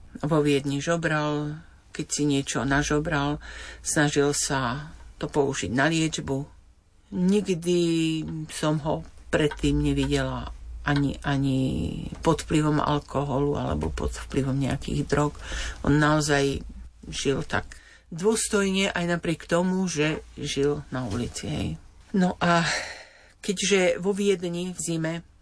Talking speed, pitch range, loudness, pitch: 115 wpm, 135-165 Hz, -26 LUFS, 145 Hz